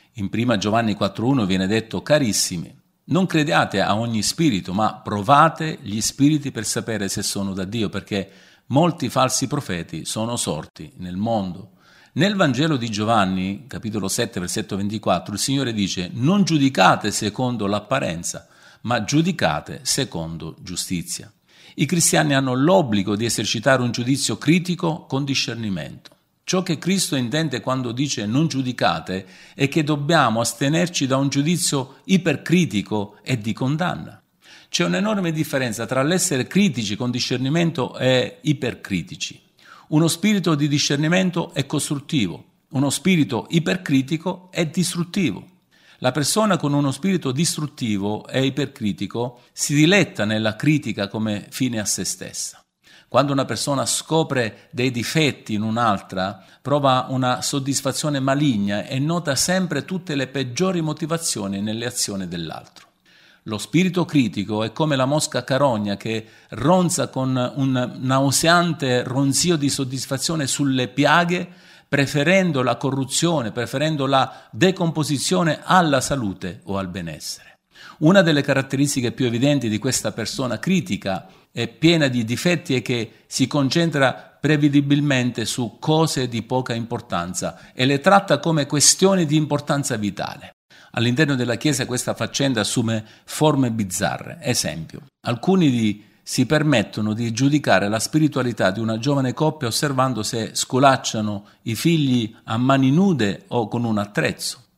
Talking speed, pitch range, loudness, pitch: 135 wpm, 110-155 Hz, -21 LUFS, 130 Hz